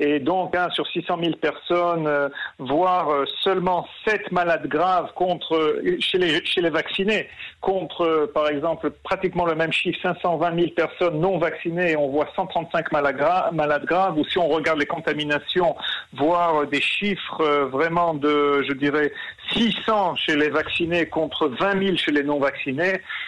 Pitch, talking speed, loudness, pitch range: 170 Hz, 165 wpm, -22 LUFS, 150-180 Hz